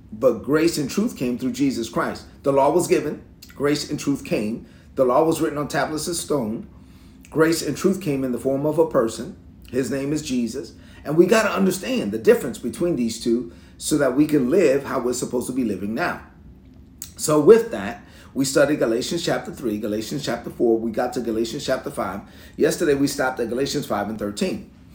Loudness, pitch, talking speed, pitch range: -22 LUFS, 135 Hz, 205 wpm, 115-155 Hz